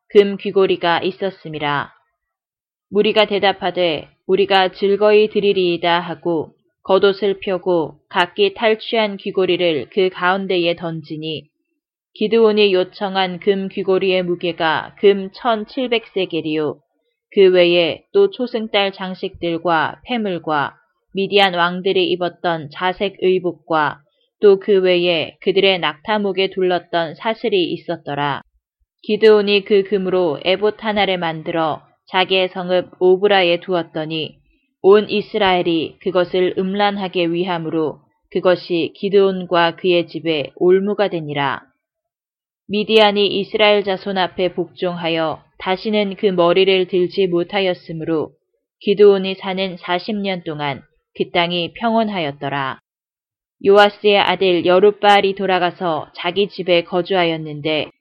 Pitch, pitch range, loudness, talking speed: 185 Hz, 170-205 Hz, -17 LUFS, 265 characters per minute